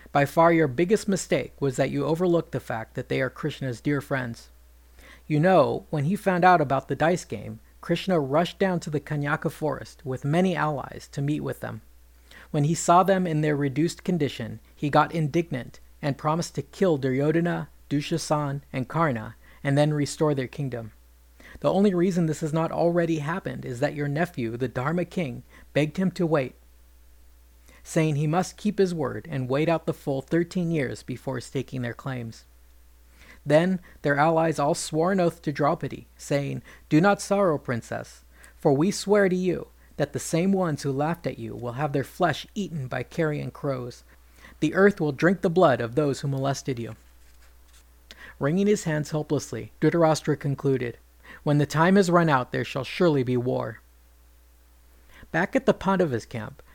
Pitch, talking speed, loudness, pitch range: 145 Hz, 180 wpm, -25 LUFS, 120-165 Hz